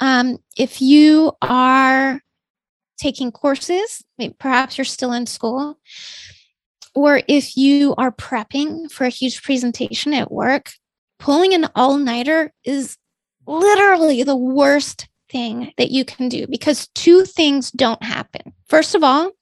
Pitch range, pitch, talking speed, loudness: 255-300 Hz, 270 Hz, 135 wpm, -16 LUFS